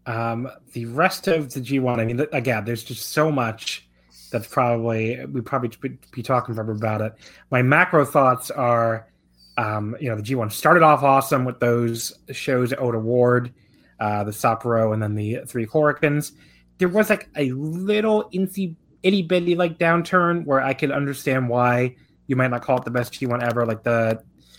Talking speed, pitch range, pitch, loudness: 180 wpm, 115-150 Hz, 125 Hz, -21 LUFS